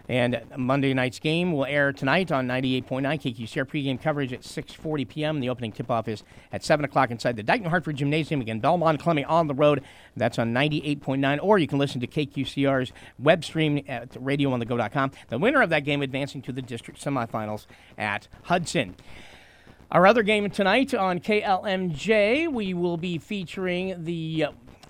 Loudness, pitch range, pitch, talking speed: -25 LUFS, 130-170 Hz, 145 Hz, 180 wpm